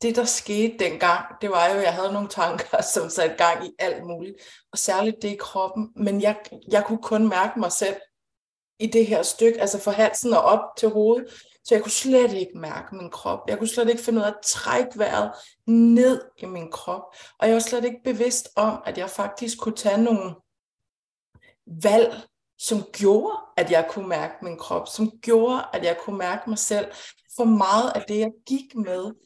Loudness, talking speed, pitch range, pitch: -22 LUFS, 205 wpm, 190-230 Hz, 210 Hz